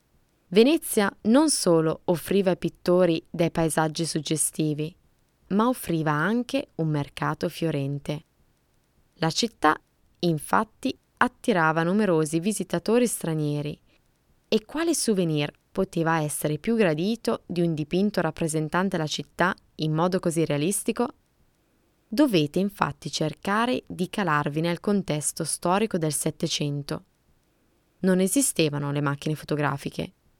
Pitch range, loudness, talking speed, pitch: 155-205 Hz, -25 LUFS, 105 wpm, 170 Hz